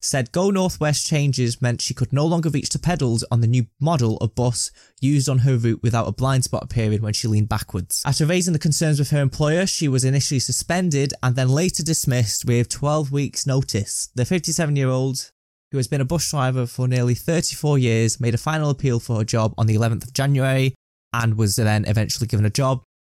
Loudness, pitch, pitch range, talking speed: -21 LUFS, 130 Hz, 115-145 Hz, 215 wpm